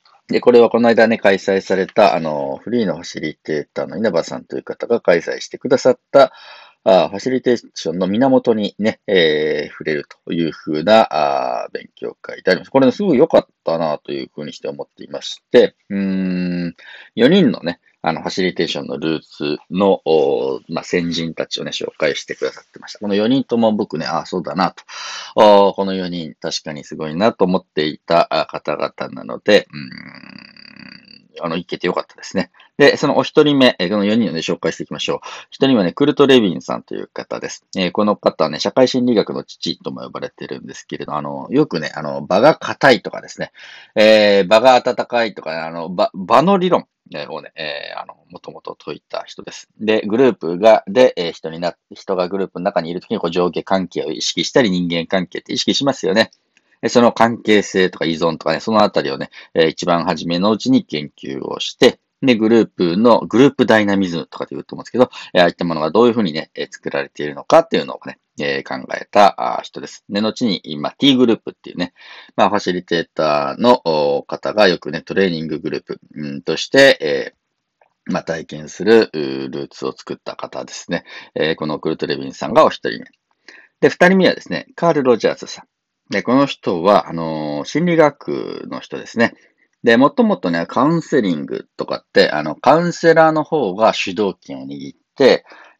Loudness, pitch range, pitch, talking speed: -16 LUFS, 85-135 Hz, 105 Hz, 380 characters per minute